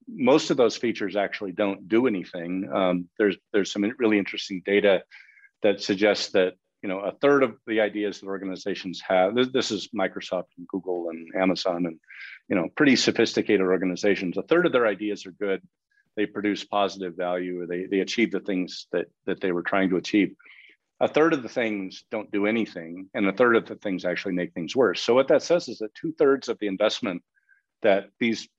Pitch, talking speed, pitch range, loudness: 100 Hz, 200 wpm, 95-110 Hz, -25 LUFS